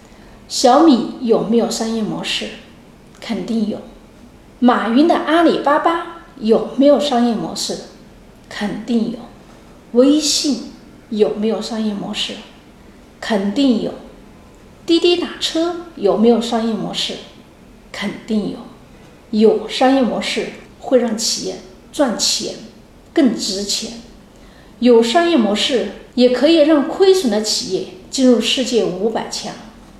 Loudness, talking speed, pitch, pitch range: -16 LUFS, 180 characters per minute, 235 Hz, 215-280 Hz